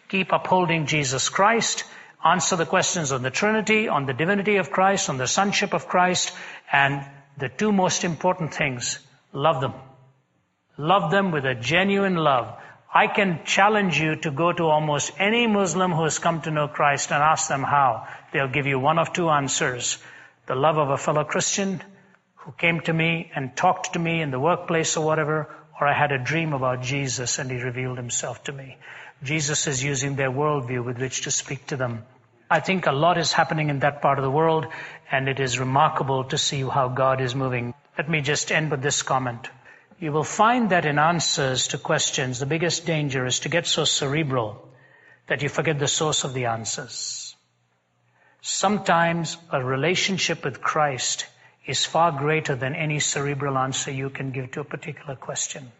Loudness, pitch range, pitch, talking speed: -23 LUFS, 135-170 Hz, 150 Hz, 190 wpm